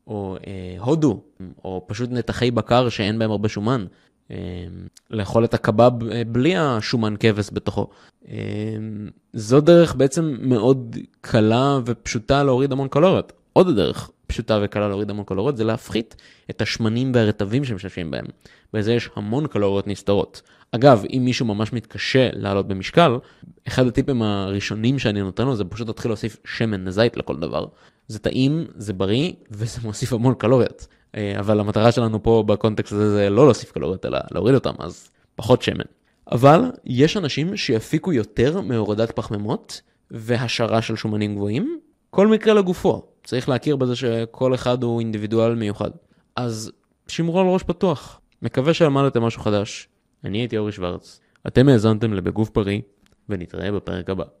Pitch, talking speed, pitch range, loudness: 115 Hz, 150 wpm, 105-130 Hz, -20 LUFS